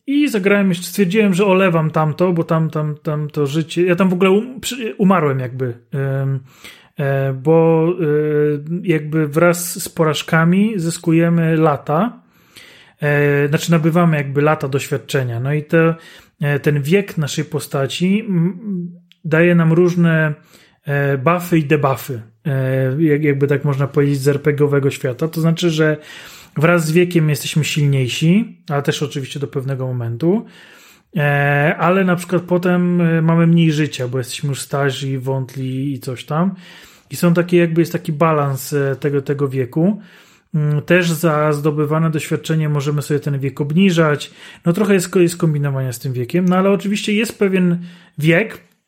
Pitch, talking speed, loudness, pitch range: 160 Hz, 140 wpm, -17 LUFS, 145-175 Hz